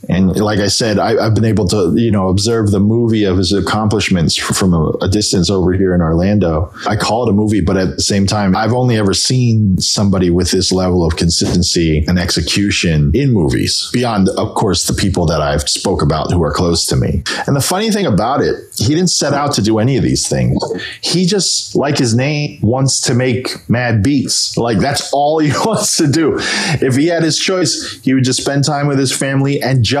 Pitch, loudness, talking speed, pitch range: 105 Hz, -13 LUFS, 220 wpm, 95-135 Hz